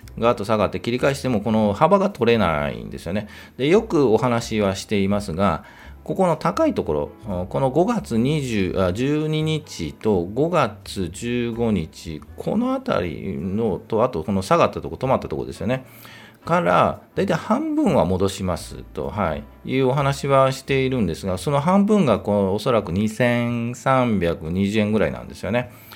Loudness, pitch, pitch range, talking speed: -21 LUFS, 115 Hz, 100-140 Hz, 310 characters per minute